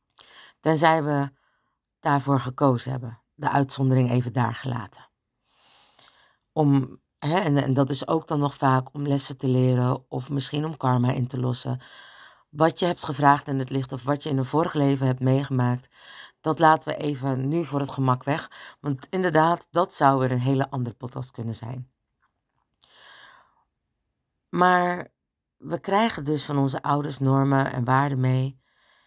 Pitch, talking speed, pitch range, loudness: 140 Hz, 160 wpm, 130-150 Hz, -24 LUFS